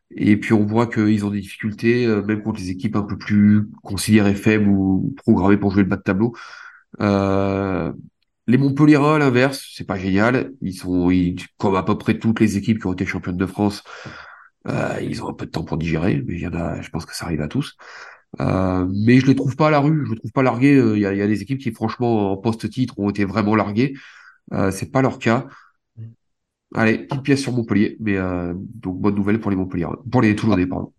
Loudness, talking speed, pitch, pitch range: -19 LUFS, 235 wpm, 105 Hz, 100-120 Hz